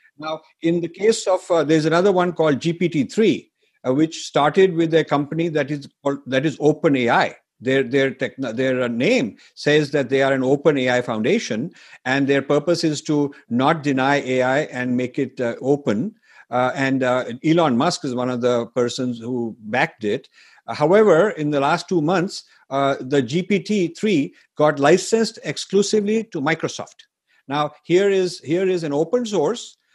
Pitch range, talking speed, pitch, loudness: 135-170 Hz, 165 wpm, 150 Hz, -20 LUFS